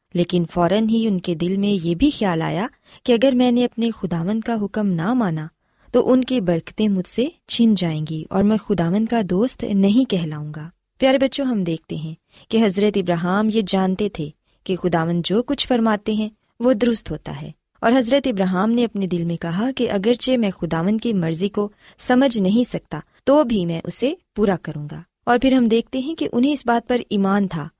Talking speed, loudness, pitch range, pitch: 205 wpm, -20 LUFS, 175-240 Hz, 210 Hz